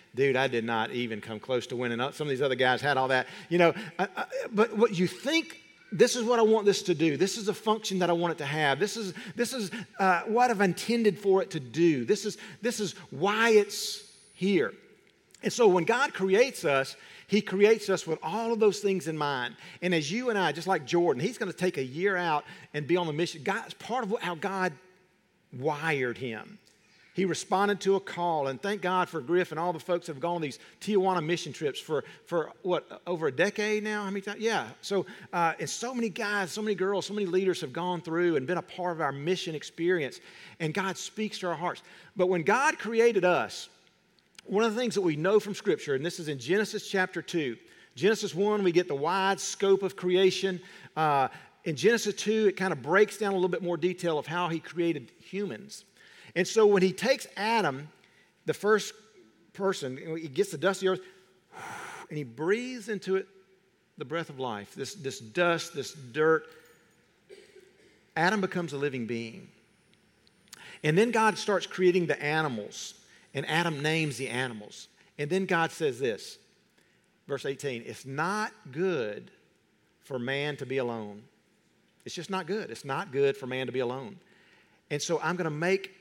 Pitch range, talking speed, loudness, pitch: 160-205 Hz, 205 wpm, -29 LUFS, 185 Hz